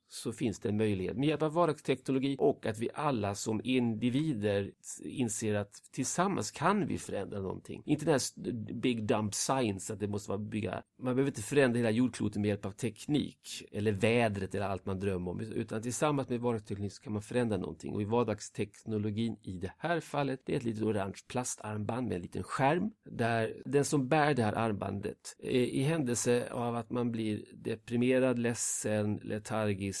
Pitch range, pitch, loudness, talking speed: 105-130 Hz, 115 Hz, -33 LUFS, 185 wpm